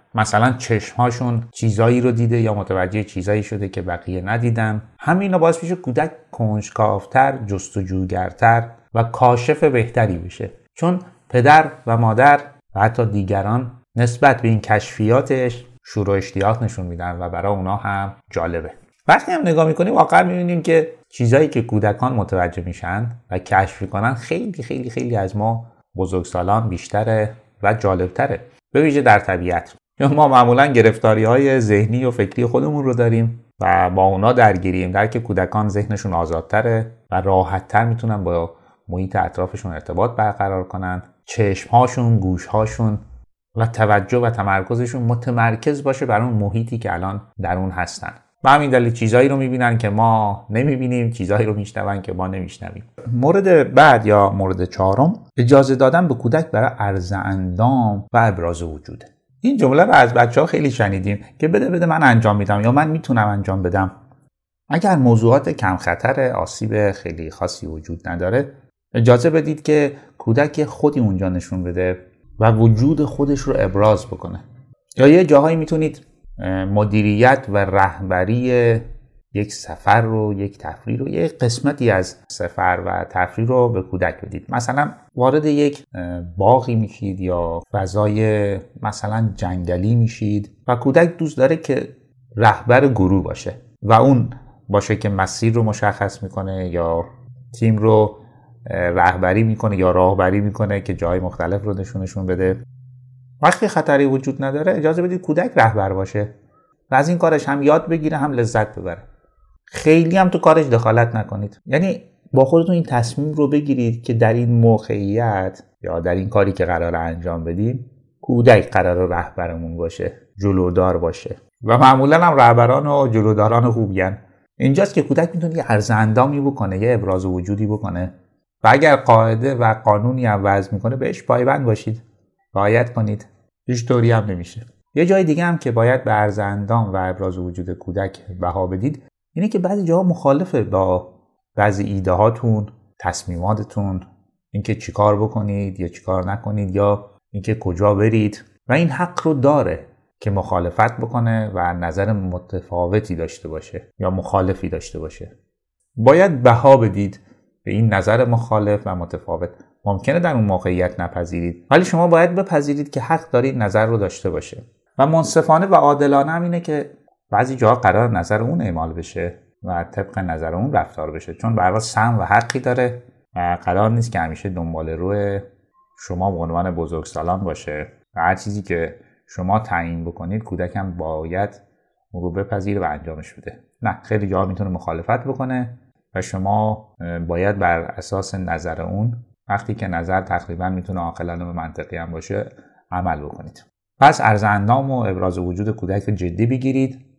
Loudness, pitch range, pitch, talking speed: -18 LUFS, 95-125 Hz, 110 Hz, 150 wpm